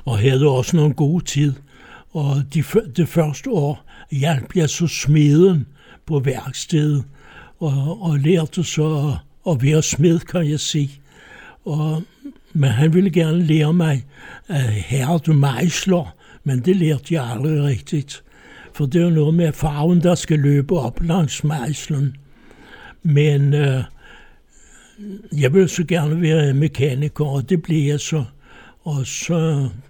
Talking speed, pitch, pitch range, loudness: 145 wpm, 150 Hz, 140-170 Hz, -18 LUFS